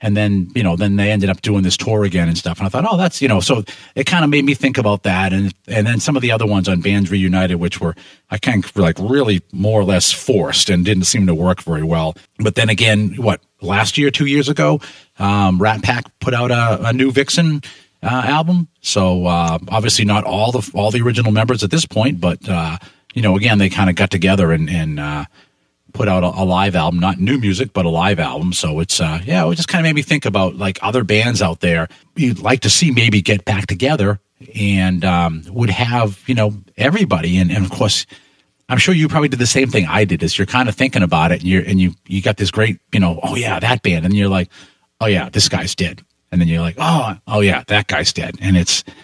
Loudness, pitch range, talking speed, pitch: -15 LUFS, 90-125 Hz, 250 wpm, 100 Hz